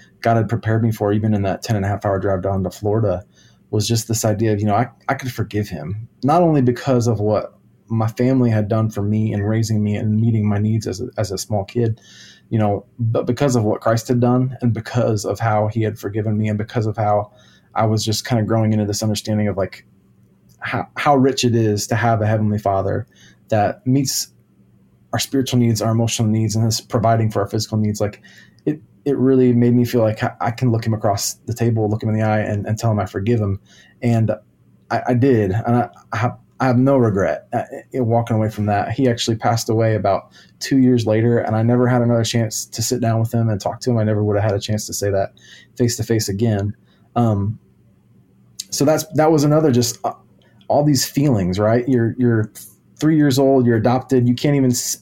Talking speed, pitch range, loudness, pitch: 235 wpm, 105-120 Hz, -19 LUFS, 115 Hz